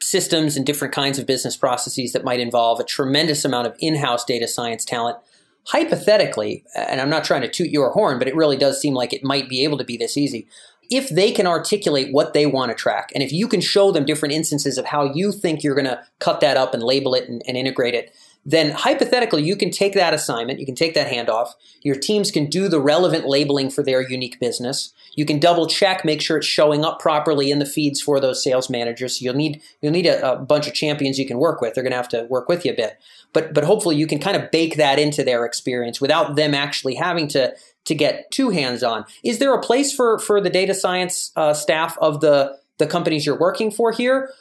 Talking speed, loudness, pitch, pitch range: 245 wpm, -19 LUFS, 150 Hz, 130-170 Hz